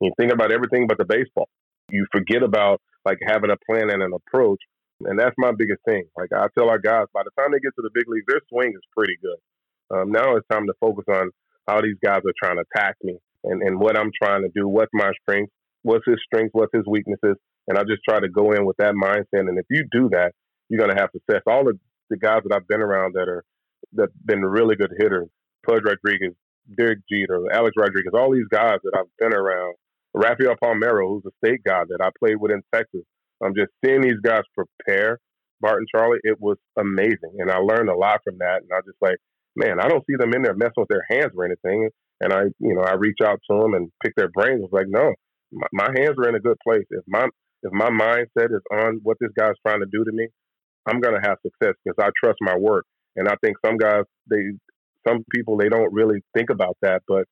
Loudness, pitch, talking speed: -21 LUFS, 110 Hz, 245 wpm